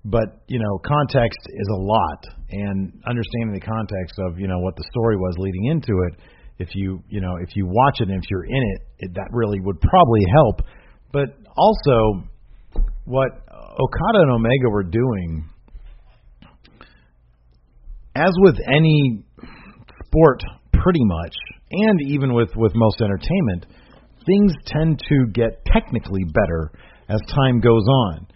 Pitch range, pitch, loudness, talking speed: 95-130 Hz, 110 Hz, -19 LUFS, 150 wpm